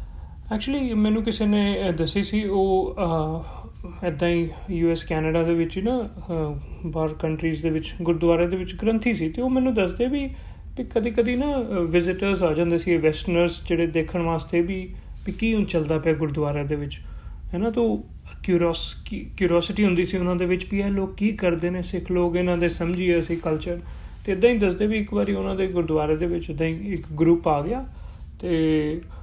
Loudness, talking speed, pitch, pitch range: -24 LUFS, 185 wpm, 175 Hz, 165-200 Hz